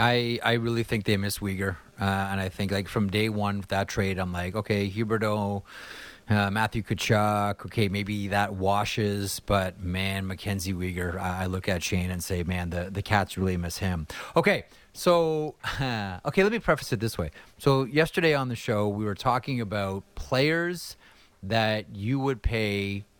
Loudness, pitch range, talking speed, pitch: -27 LUFS, 95-115 Hz, 180 wpm, 100 Hz